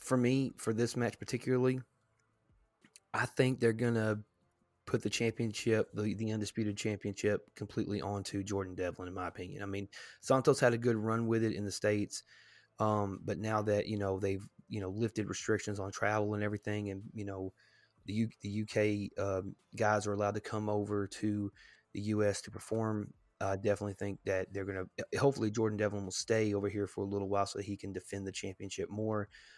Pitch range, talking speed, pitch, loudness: 100-110 Hz, 195 wpm, 105 Hz, -35 LUFS